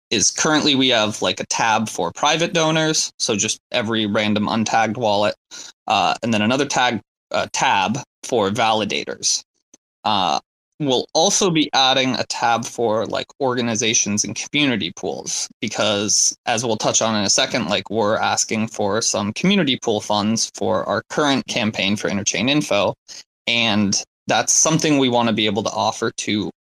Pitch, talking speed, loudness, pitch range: 115 Hz, 160 wpm, -19 LUFS, 105-140 Hz